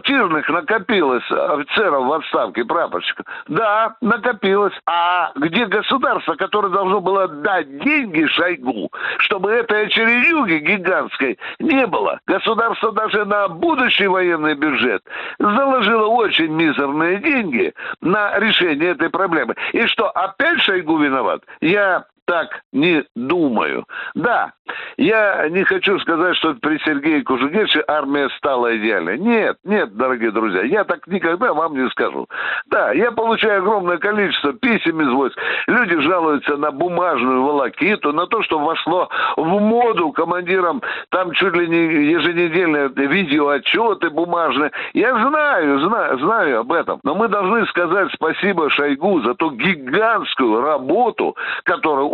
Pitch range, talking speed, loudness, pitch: 165-240 Hz, 130 wpm, -17 LUFS, 200 Hz